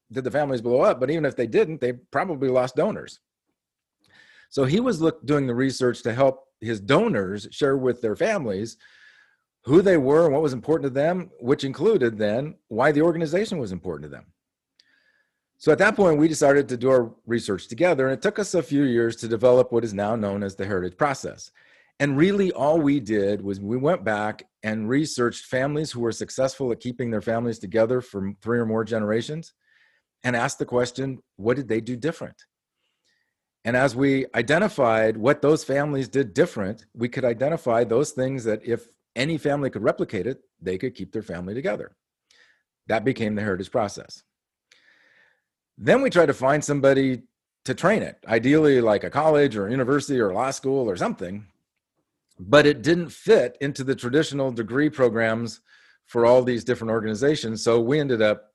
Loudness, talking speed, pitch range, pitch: -23 LUFS, 185 wpm, 115-145 Hz, 125 Hz